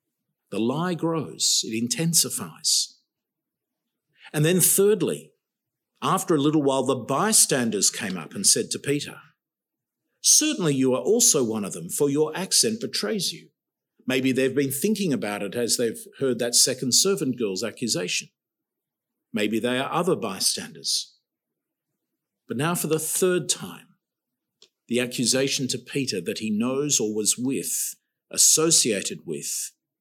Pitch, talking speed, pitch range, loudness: 145 Hz, 140 wpm, 130-175 Hz, -22 LUFS